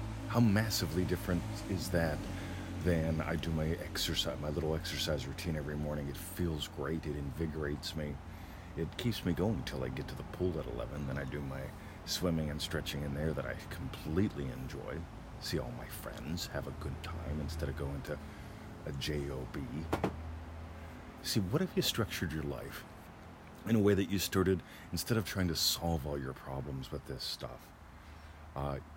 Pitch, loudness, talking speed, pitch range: 80 Hz, -37 LUFS, 180 wpm, 75-90 Hz